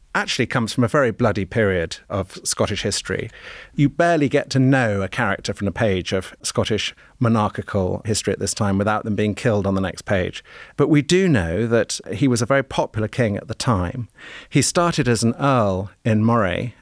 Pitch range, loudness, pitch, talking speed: 100-130 Hz, -20 LUFS, 115 Hz, 200 wpm